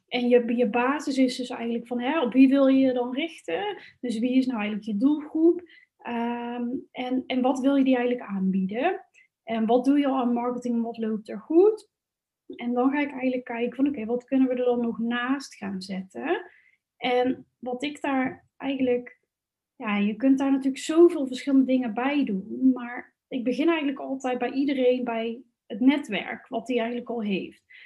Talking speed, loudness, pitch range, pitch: 195 wpm, -25 LUFS, 240-275 Hz, 255 Hz